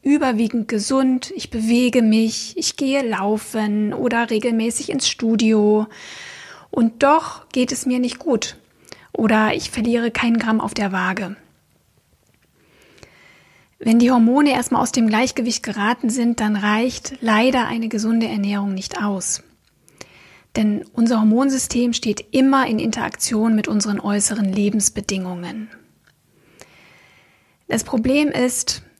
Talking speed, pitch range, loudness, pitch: 120 wpm, 215-250 Hz, -19 LUFS, 230 Hz